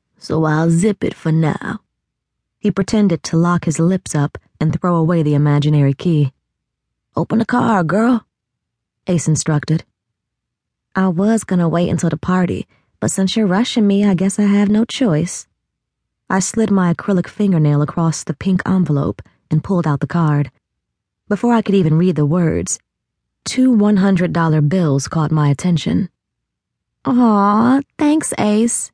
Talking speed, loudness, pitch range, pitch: 155 wpm, -16 LUFS, 155-205 Hz, 180 Hz